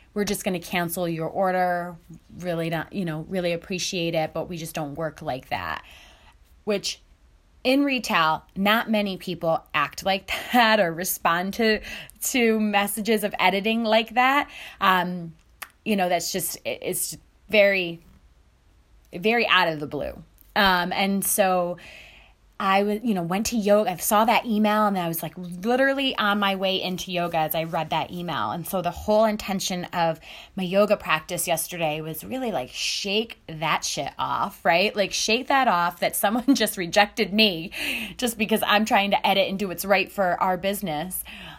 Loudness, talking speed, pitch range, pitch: -23 LUFS, 170 wpm, 170-210 Hz, 185 Hz